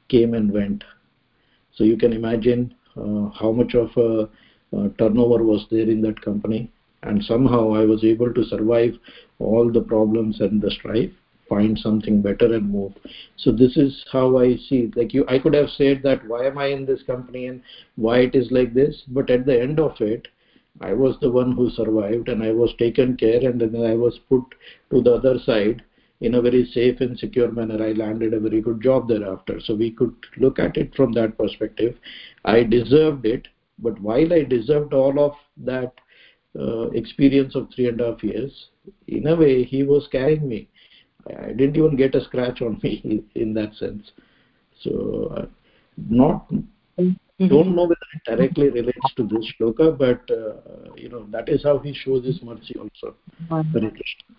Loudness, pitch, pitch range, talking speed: -20 LUFS, 125 Hz, 110-135 Hz, 195 wpm